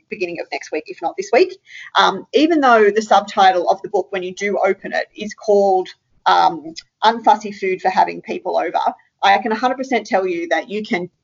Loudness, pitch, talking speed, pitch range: -17 LUFS, 200 Hz, 205 wpm, 185-230 Hz